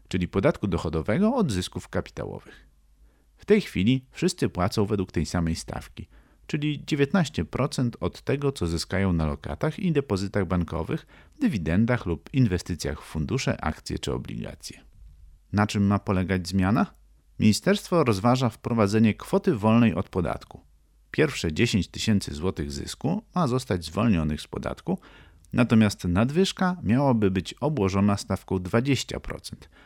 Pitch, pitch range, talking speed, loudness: 100 Hz, 85-130 Hz, 125 wpm, -26 LUFS